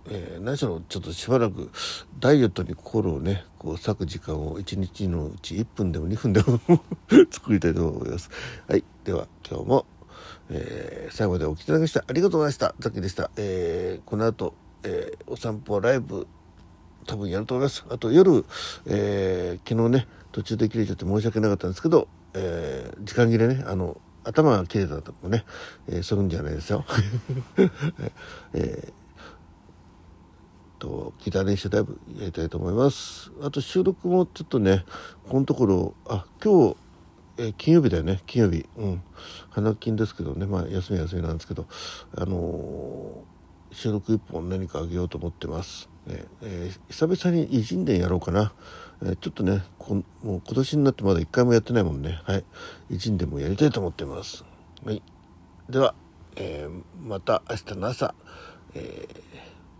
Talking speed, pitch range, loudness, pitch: 325 characters per minute, 85-115 Hz, -25 LUFS, 95 Hz